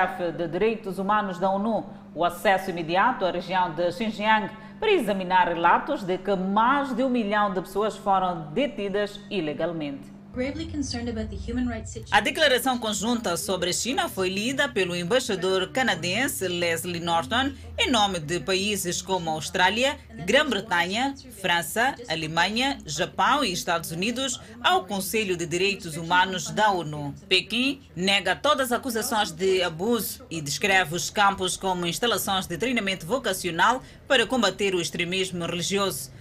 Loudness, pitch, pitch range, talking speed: -25 LUFS, 190 Hz, 175-225 Hz, 135 wpm